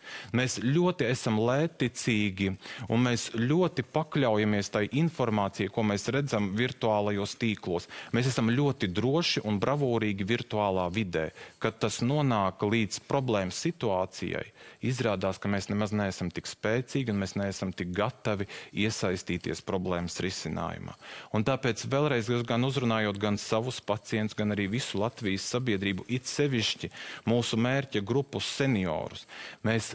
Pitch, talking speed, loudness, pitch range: 110 Hz, 120 wpm, -30 LUFS, 100-125 Hz